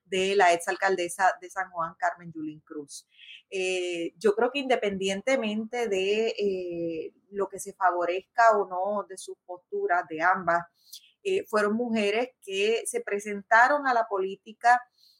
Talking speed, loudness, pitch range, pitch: 140 wpm, -27 LUFS, 180-225 Hz, 195 Hz